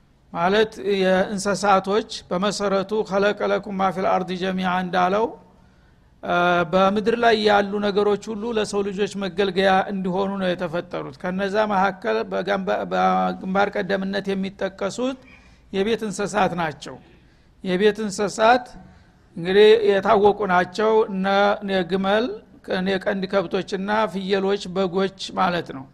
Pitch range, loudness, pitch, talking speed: 185-210 Hz, -21 LUFS, 195 Hz, 90 wpm